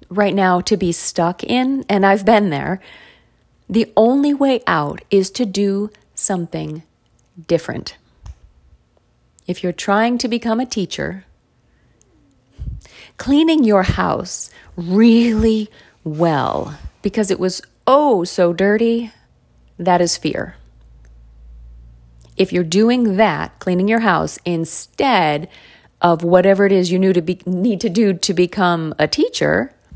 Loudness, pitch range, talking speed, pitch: -16 LUFS, 170-220 Hz, 125 wpm, 185 Hz